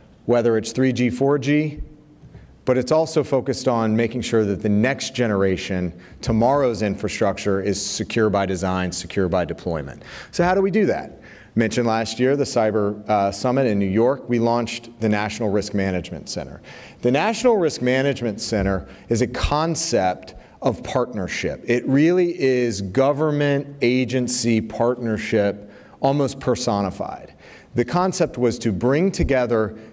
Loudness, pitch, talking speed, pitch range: -21 LUFS, 120 Hz, 140 wpm, 105-135 Hz